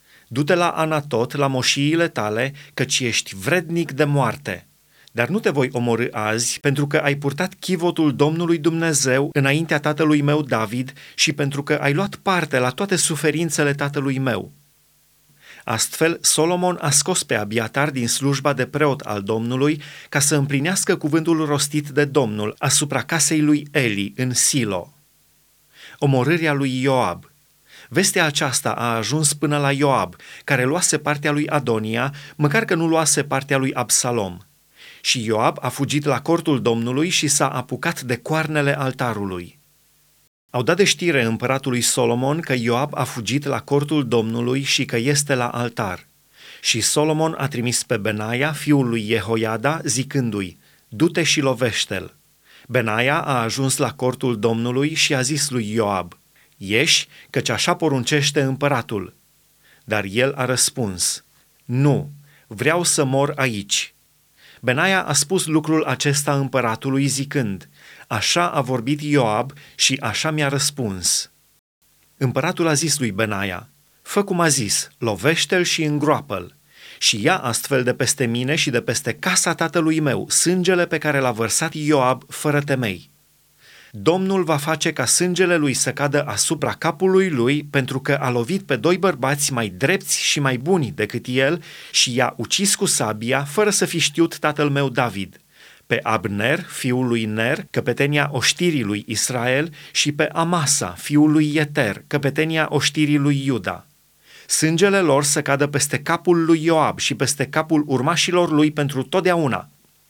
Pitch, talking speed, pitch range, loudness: 140 Hz, 150 wpm, 125-155 Hz, -19 LUFS